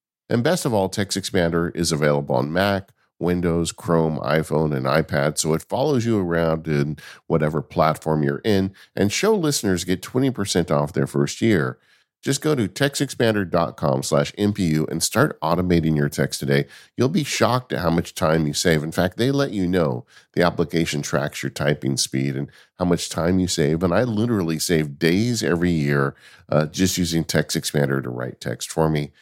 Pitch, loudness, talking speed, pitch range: 85 Hz, -21 LUFS, 180 wpm, 75-95 Hz